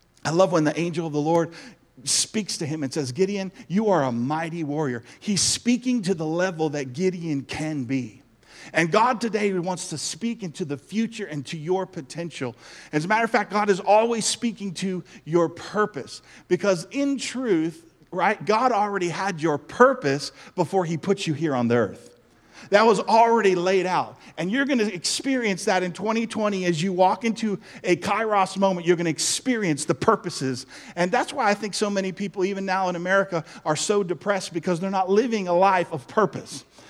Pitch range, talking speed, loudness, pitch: 165-210 Hz, 190 wpm, -24 LUFS, 185 Hz